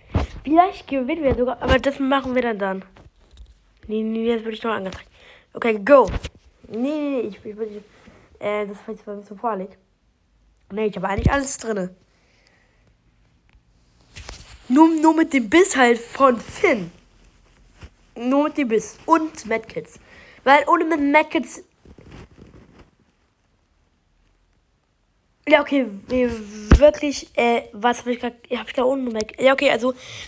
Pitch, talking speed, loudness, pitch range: 245 Hz, 140 wpm, -20 LUFS, 215-280 Hz